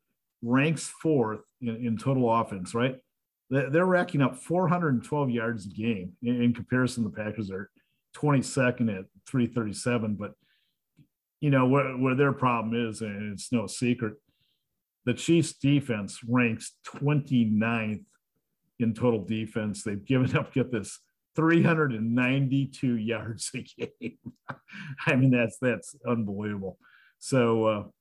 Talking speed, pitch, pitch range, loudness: 130 wpm, 120 Hz, 110-135 Hz, -27 LUFS